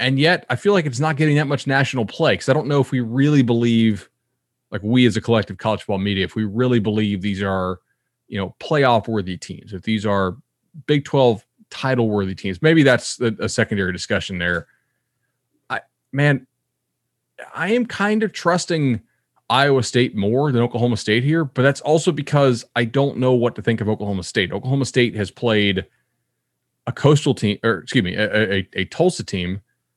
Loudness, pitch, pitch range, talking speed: -19 LUFS, 120 Hz, 105-140 Hz, 190 wpm